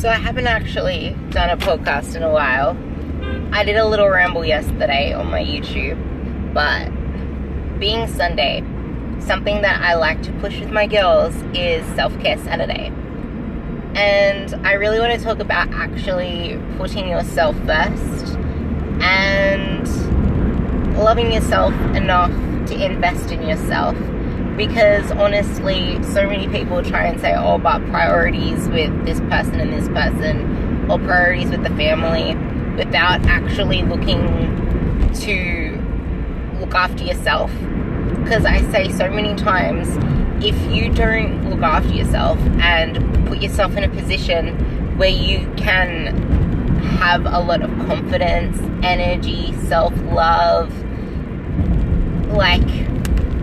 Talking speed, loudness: 125 wpm, -18 LUFS